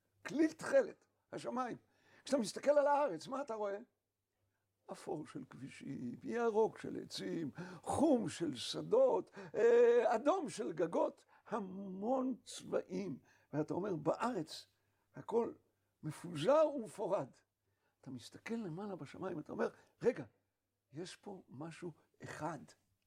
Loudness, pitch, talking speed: -38 LUFS, 210 Hz, 105 wpm